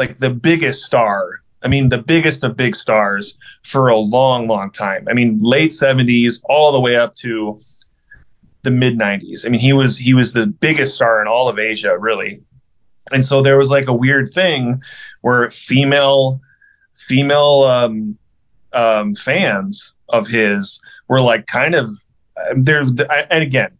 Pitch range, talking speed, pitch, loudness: 115-140 Hz, 165 wpm, 130 Hz, -14 LUFS